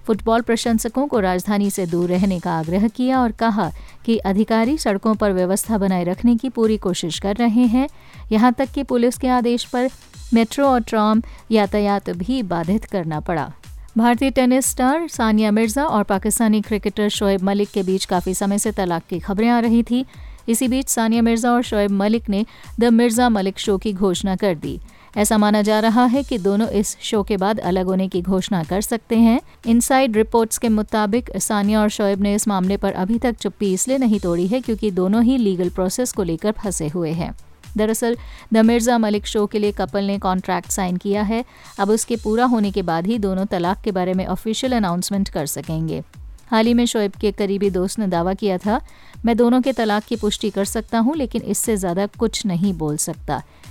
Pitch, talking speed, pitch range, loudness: 215 Hz, 200 wpm, 195-235 Hz, -19 LUFS